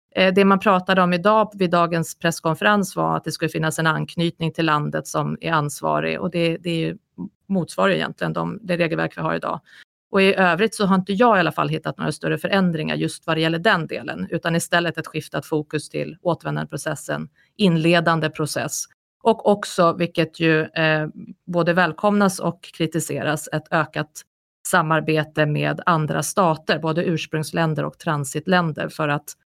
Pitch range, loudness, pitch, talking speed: 155-185 Hz, -21 LUFS, 165 Hz, 165 wpm